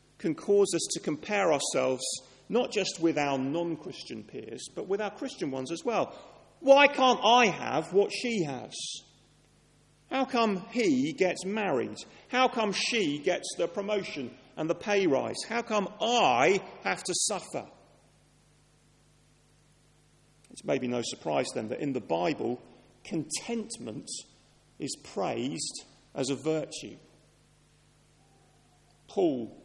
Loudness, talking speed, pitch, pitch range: -29 LUFS, 130 wpm, 200 Hz, 155-235 Hz